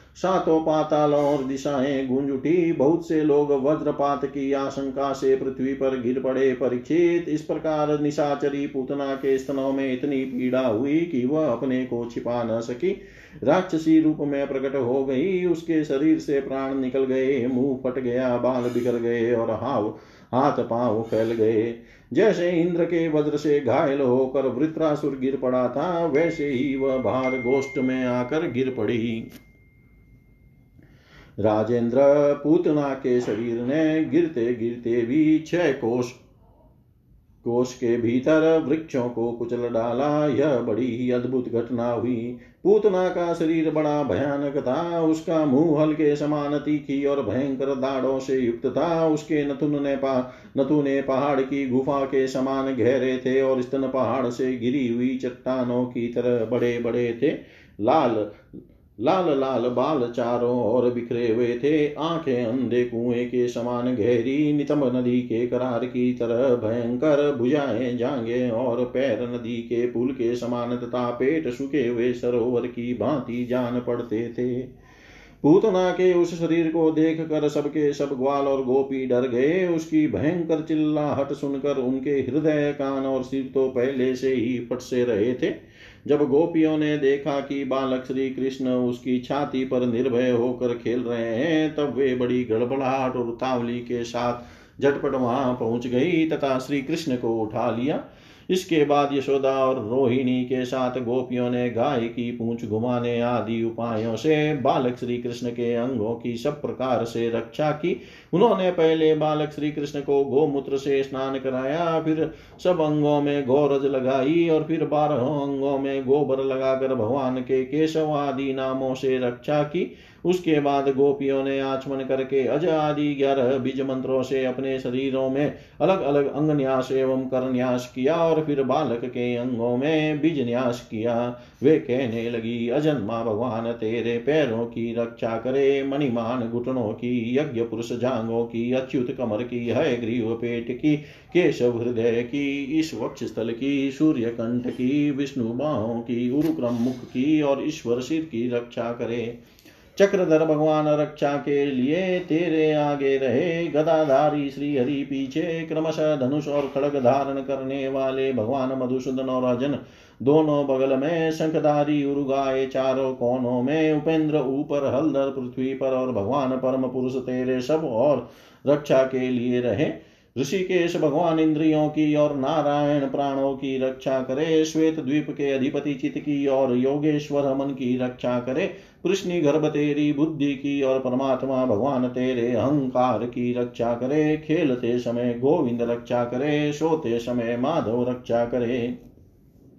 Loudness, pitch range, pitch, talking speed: -23 LUFS, 125-145 Hz, 135 Hz, 150 wpm